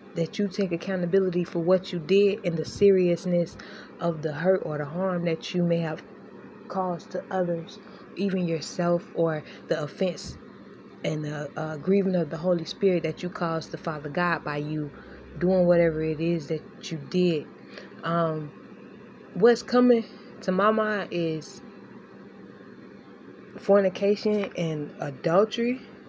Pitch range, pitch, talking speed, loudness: 165-200 Hz, 175 Hz, 145 wpm, -26 LUFS